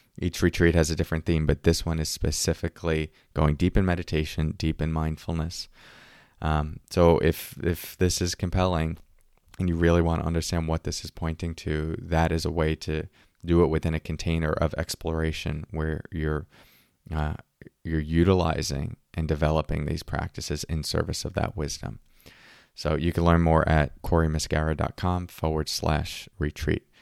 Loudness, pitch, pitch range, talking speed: -27 LUFS, 80 Hz, 80-85 Hz, 160 wpm